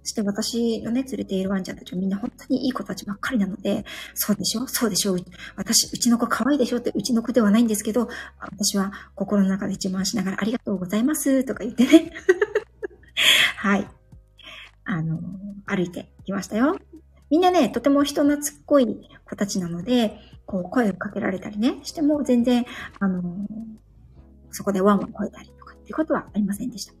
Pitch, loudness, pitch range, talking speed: 220 Hz, -23 LUFS, 195-255 Hz, 395 characters per minute